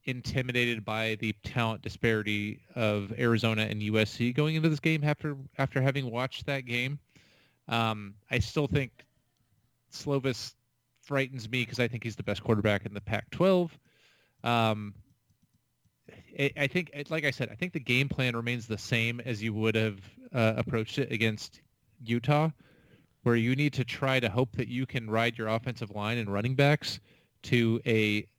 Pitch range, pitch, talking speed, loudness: 110-135 Hz, 120 Hz, 165 wpm, -30 LUFS